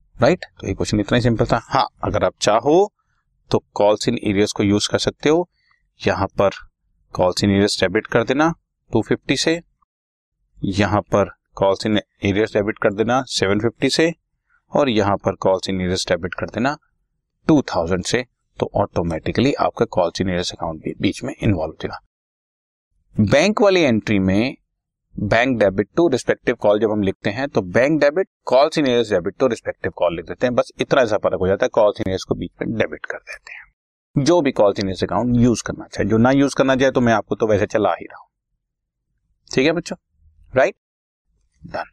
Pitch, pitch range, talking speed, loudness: 105 Hz, 95-125 Hz, 180 wpm, -19 LUFS